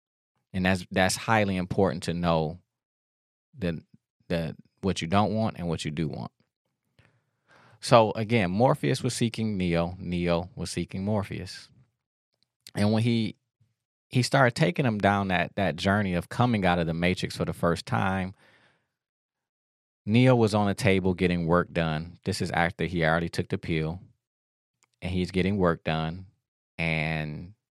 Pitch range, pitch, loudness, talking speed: 85-110 Hz, 90 Hz, -26 LUFS, 155 wpm